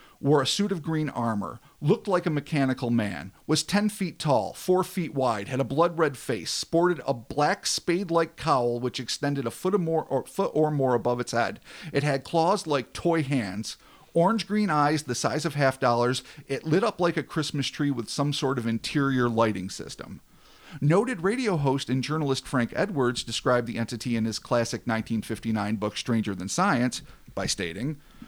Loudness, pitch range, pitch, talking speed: -26 LUFS, 120-165 Hz, 140 Hz, 190 wpm